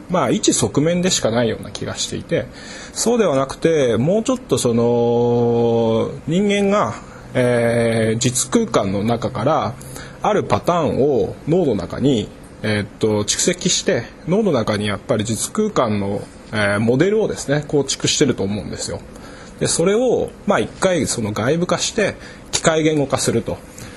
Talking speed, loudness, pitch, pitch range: 285 characters per minute, -18 LUFS, 120 Hz, 110-165 Hz